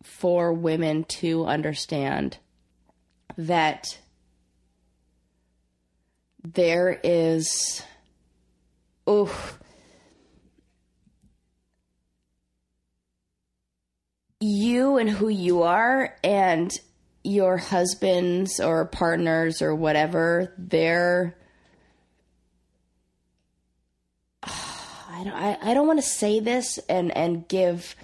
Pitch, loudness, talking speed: 160 Hz, -24 LUFS, 75 wpm